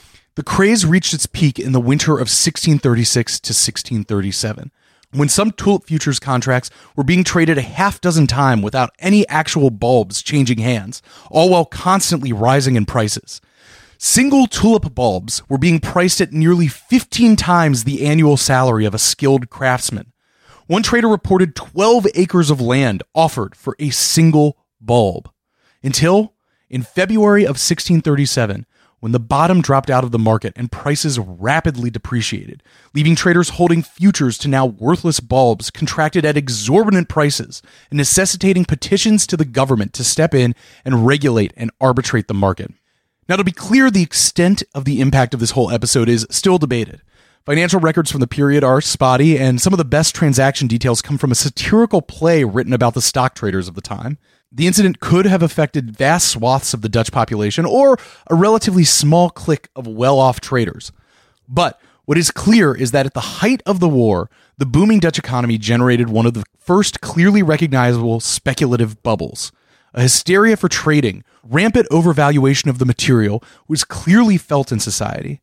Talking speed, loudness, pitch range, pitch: 170 wpm, -15 LUFS, 120-170 Hz, 140 Hz